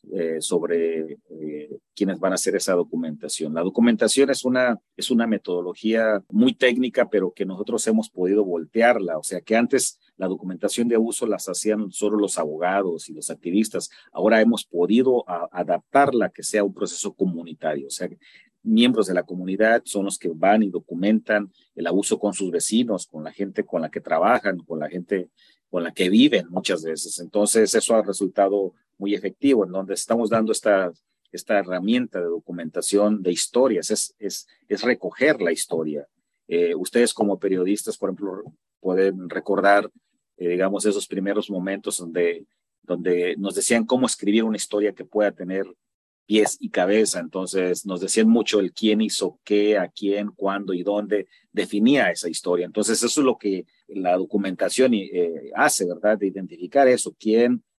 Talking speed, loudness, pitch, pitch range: 170 wpm, -22 LUFS, 100 Hz, 90-110 Hz